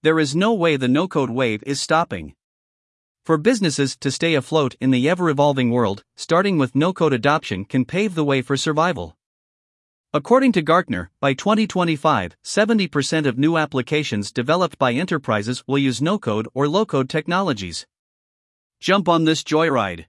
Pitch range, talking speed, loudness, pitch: 130-170 Hz, 165 wpm, -20 LUFS, 150 Hz